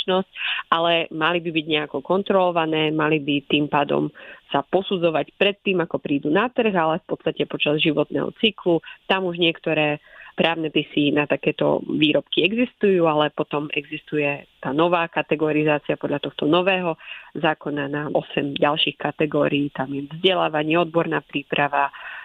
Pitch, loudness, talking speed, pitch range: 155 Hz, -21 LUFS, 140 wpm, 150-175 Hz